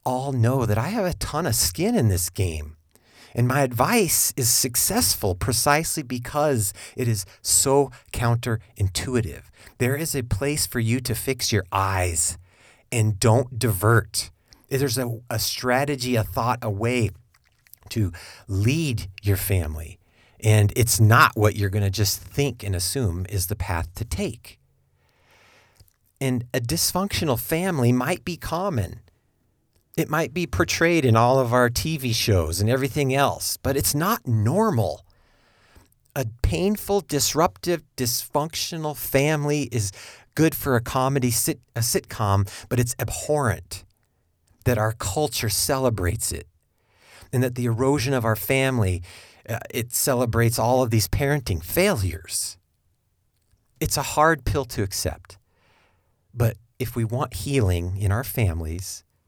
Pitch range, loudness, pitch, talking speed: 100-130 Hz, -23 LUFS, 115 Hz, 140 wpm